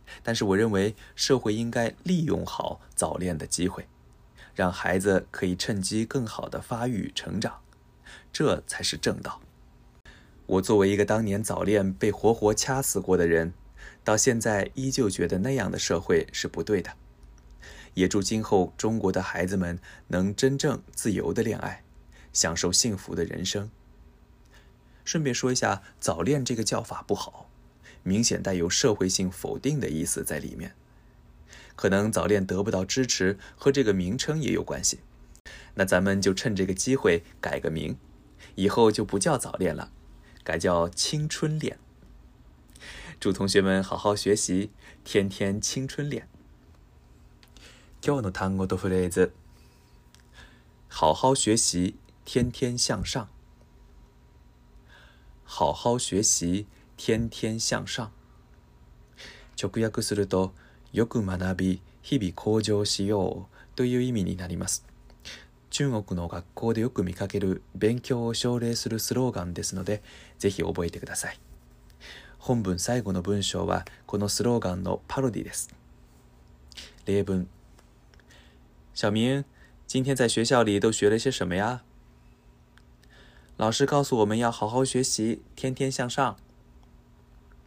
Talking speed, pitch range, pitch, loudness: 220 characters per minute, 70-115 Hz, 95 Hz, -27 LUFS